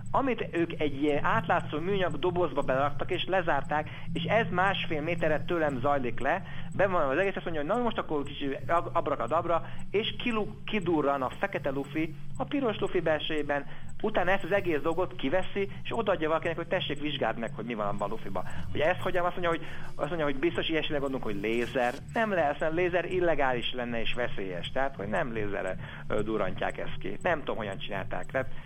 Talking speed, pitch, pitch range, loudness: 190 wpm, 160 Hz, 145-180 Hz, -30 LUFS